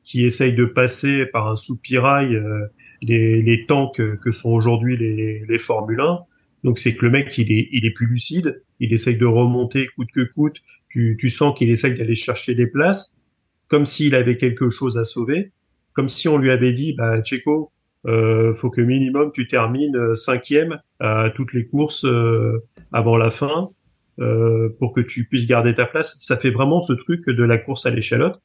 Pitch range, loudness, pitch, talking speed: 115-135 Hz, -19 LUFS, 125 Hz, 190 wpm